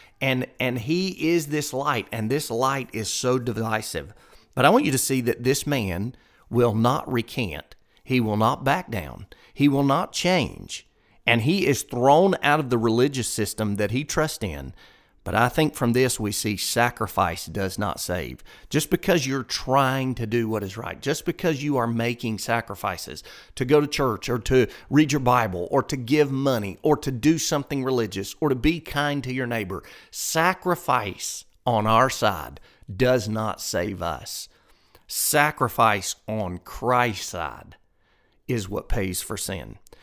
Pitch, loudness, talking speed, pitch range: 125 Hz, -24 LUFS, 170 wpm, 110-140 Hz